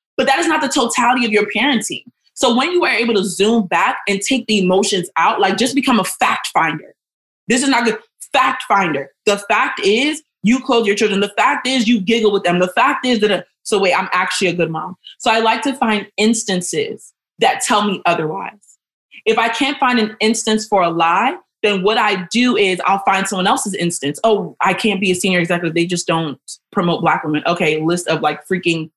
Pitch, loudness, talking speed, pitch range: 210 Hz, -16 LUFS, 220 wpm, 180-240 Hz